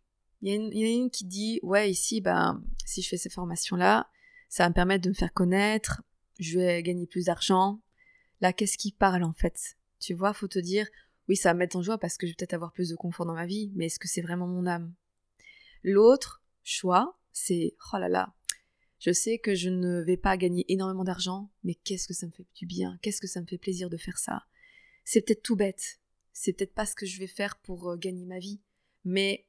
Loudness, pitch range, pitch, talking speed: -29 LUFS, 180-210 Hz, 190 Hz, 235 wpm